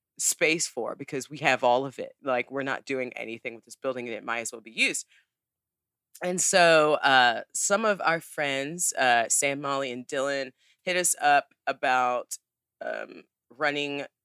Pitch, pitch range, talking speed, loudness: 140 Hz, 125-155 Hz, 175 wpm, -26 LUFS